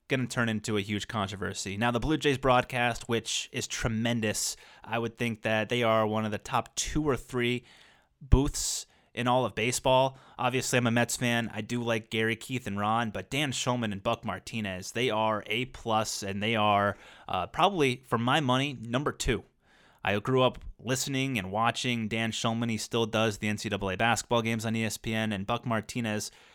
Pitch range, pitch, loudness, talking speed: 110-125 Hz, 115 Hz, -29 LUFS, 190 wpm